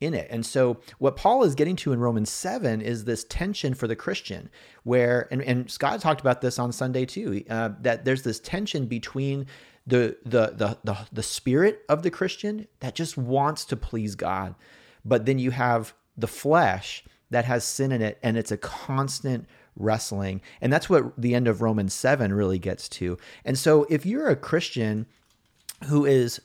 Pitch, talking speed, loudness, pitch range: 125 Hz, 190 wpm, -25 LUFS, 115-140 Hz